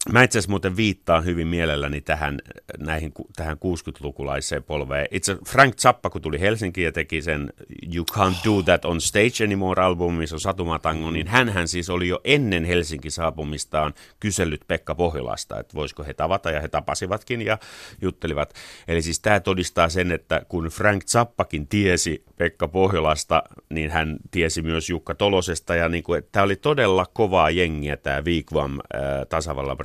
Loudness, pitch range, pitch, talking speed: -23 LUFS, 80-95 Hz, 85 Hz, 165 wpm